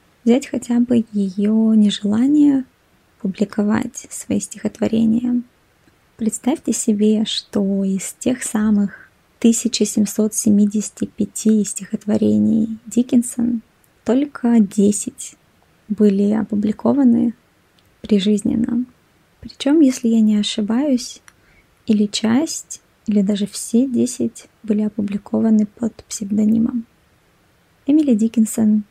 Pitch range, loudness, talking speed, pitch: 210-240 Hz, -18 LUFS, 80 wpm, 220 Hz